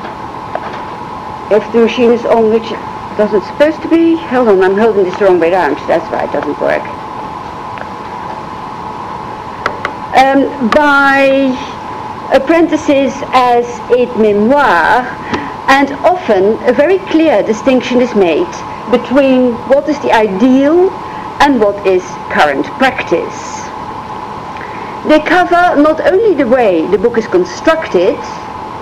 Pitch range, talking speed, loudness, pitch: 215-295 Hz, 125 wpm, -11 LUFS, 255 Hz